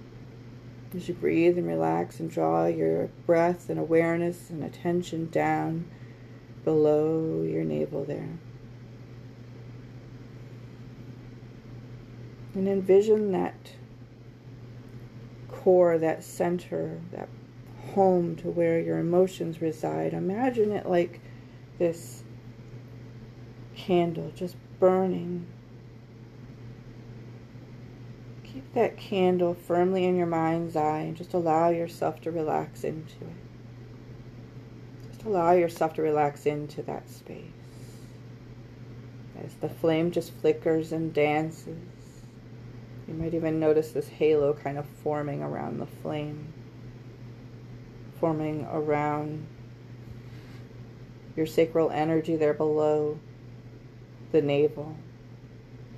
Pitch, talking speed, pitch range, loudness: 125 Hz, 95 wpm, 120-160 Hz, -27 LUFS